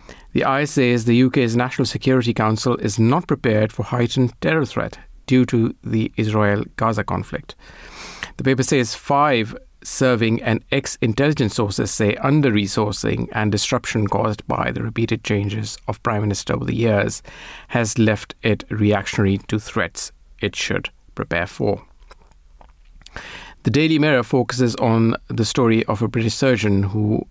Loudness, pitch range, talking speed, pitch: -20 LUFS, 105-125 Hz, 150 wpm, 115 Hz